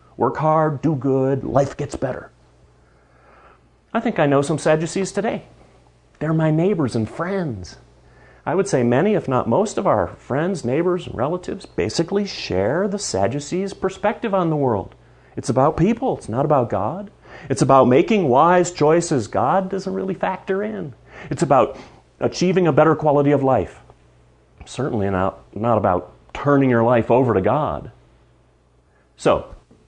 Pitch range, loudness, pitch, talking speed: 115-180 Hz, -19 LUFS, 140 Hz, 155 wpm